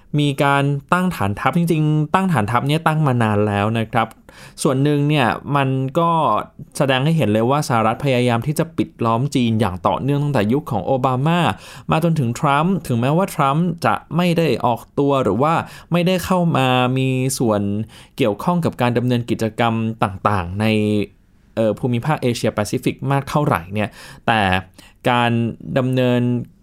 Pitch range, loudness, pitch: 110-150 Hz, -18 LUFS, 130 Hz